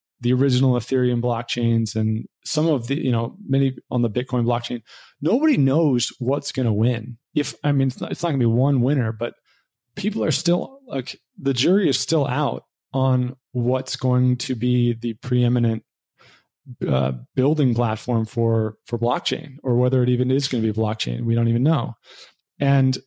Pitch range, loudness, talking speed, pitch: 120-135 Hz, -22 LUFS, 180 wpm, 125 Hz